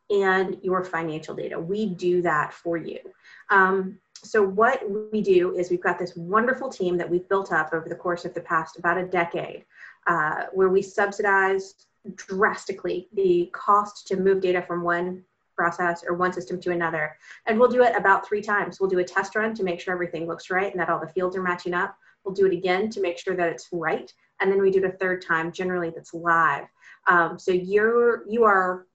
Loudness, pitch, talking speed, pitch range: -24 LUFS, 185 Hz, 215 wpm, 175-200 Hz